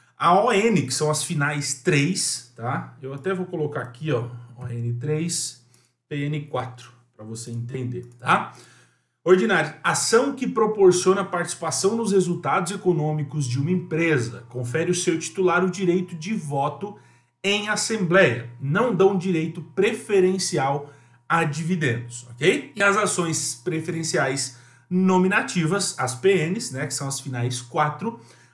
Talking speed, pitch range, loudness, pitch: 130 wpm, 130-185 Hz, -23 LUFS, 155 Hz